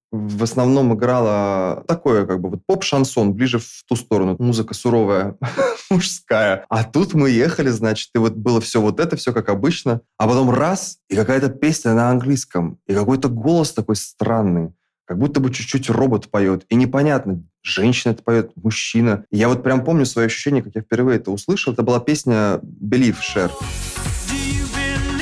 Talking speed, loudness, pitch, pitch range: 170 wpm, -18 LUFS, 120 Hz, 110-135 Hz